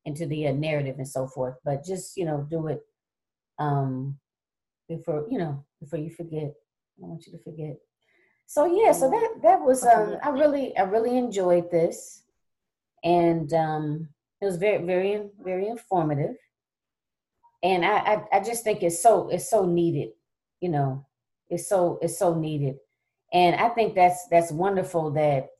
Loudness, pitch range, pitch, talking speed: -25 LUFS, 150-200 Hz, 170 Hz, 170 wpm